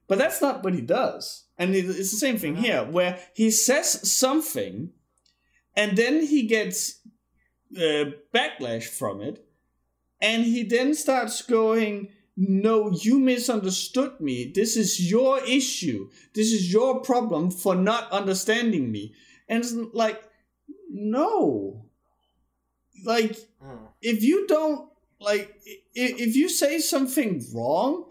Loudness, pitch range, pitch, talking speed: -24 LUFS, 190-255 Hz, 220 Hz, 125 wpm